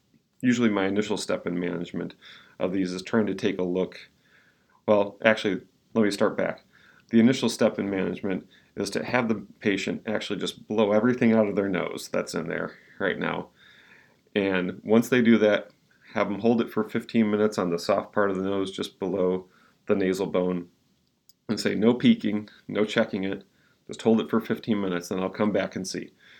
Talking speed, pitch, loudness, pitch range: 195 wpm, 100 Hz, -26 LUFS, 95-110 Hz